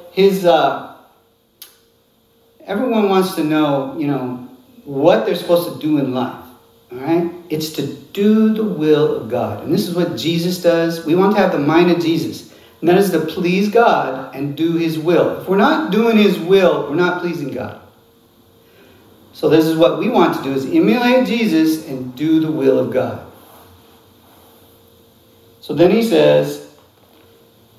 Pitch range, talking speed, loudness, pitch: 115-175 Hz, 170 wpm, -16 LUFS, 155 Hz